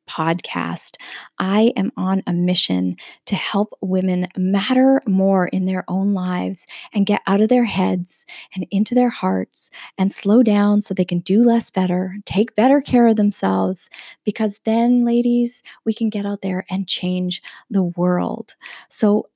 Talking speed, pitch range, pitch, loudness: 160 wpm, 180-220 Hz, 195 Hz, -19 LUFS